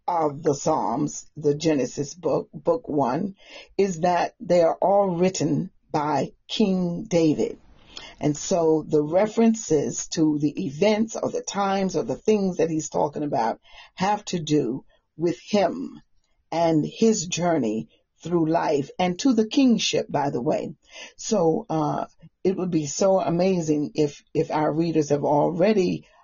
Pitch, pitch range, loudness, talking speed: 165 Hz, 150-195 Hz, -24 LUFS, 145 wpm